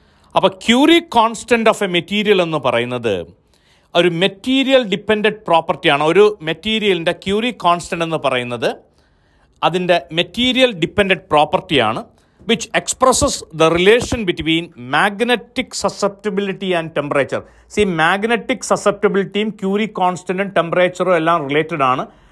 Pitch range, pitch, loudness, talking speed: 165-215 Hz, 190 Hz, -16 LUFS, 110 wpm